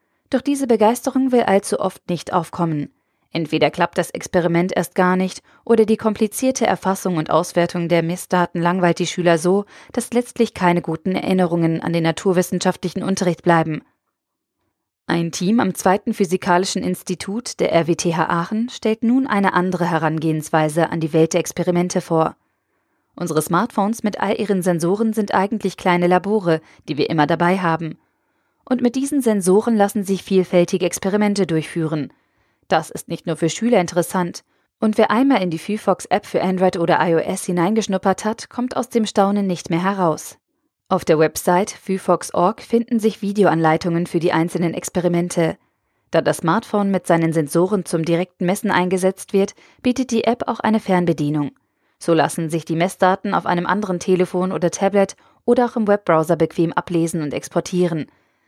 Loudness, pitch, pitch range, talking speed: -19 LUFS, 180 Hz, 170-205 Hz, 160 wpm